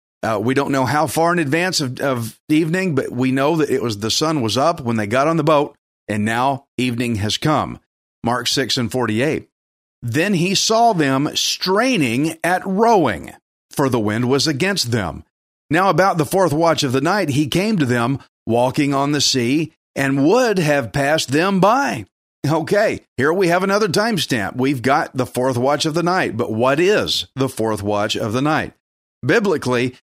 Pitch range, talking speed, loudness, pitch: 120-165 Hz, 190 wpm, -18 LUFS, 140 Hz